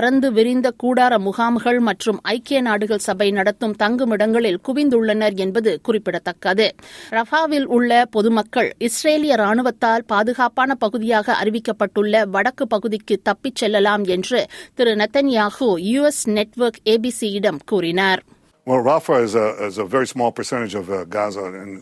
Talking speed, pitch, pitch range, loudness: 90 wpm, 220 Hz, 205-245 Hz, -18 LUFS